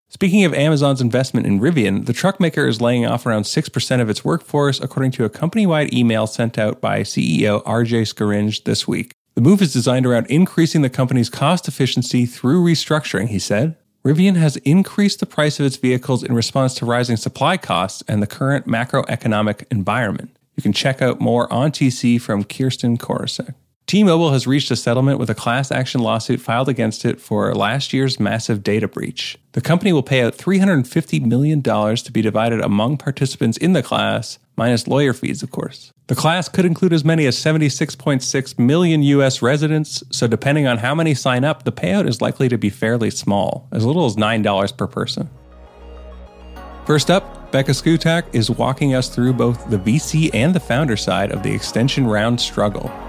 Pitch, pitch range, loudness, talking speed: 130 Hz, 115-150 Hz, -17 LUFS, 185 wpm